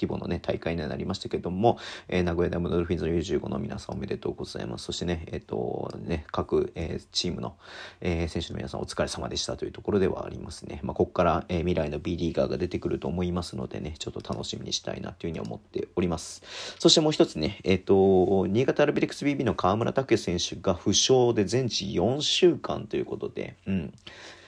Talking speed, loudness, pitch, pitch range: 460 characters per minute, -27 LUFS, 90 Hz, 85-125 Hz